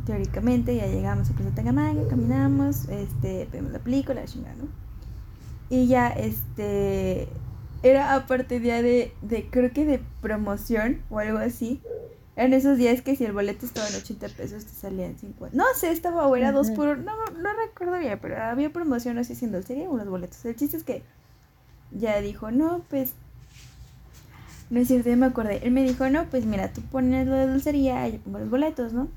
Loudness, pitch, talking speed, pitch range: -25 LUFS, 245 Hz, 195 wpm, 180-270 Hz